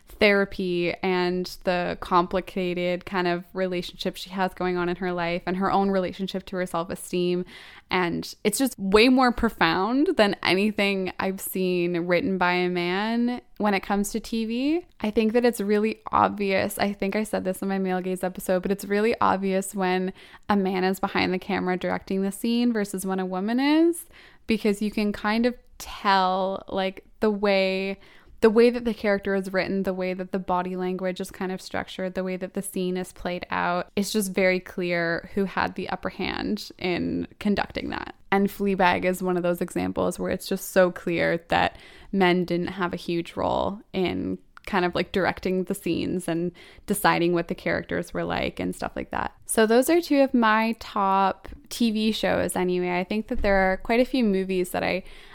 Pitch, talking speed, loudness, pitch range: 190 Hz, 195 wpm, -25 LUFS, 180-205 Hz